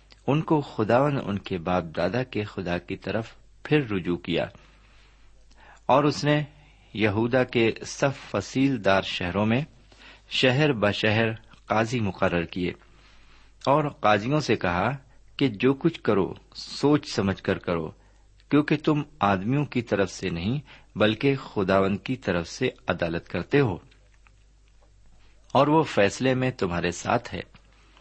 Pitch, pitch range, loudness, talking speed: 110 Hz, 95-140 Hz, -25 LUFS, 135 wpm